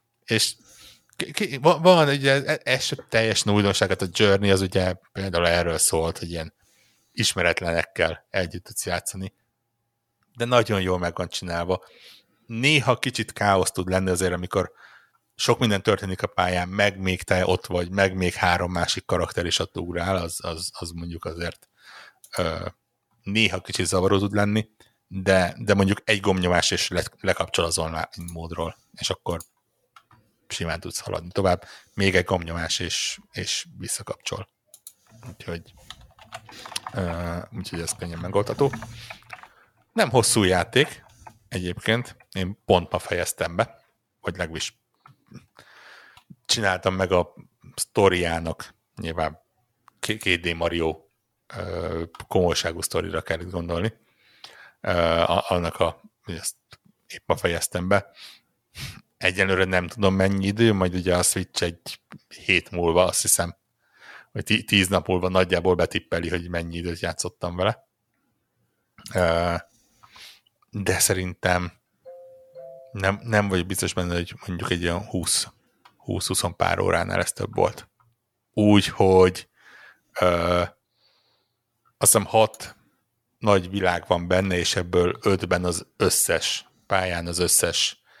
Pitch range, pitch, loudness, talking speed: 90-105 Hz, 95 Hz, -23 LUFS, 120 wpm